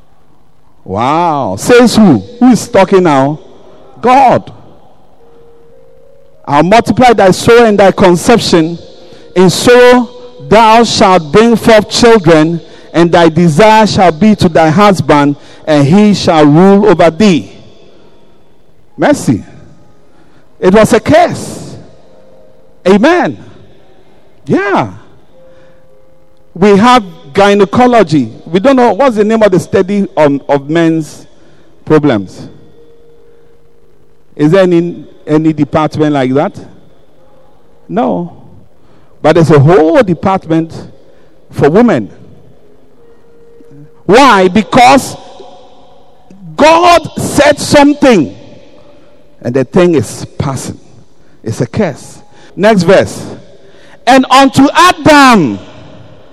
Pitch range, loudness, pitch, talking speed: 160-245 Hz, -7 LUFS, 195 Hz, 100 wpm